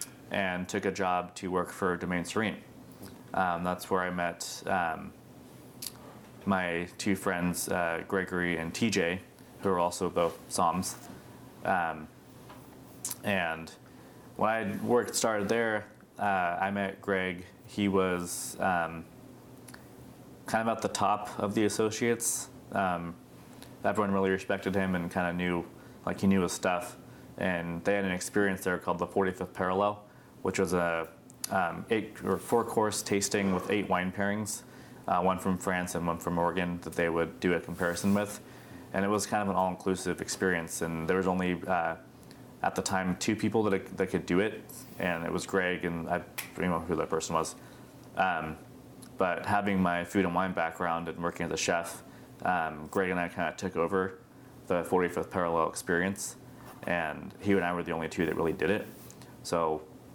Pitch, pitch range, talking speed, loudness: 95 Hz, 85-100 Hz, 175 wpm, -31 LUFS